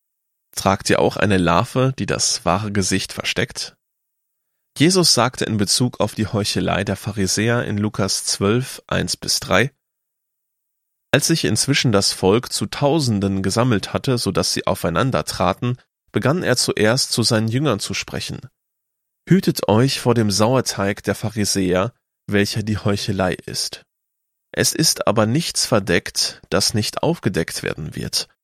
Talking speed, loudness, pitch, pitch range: 140 wpm, -19 LUFS, 105 Hz, 100-125 Hz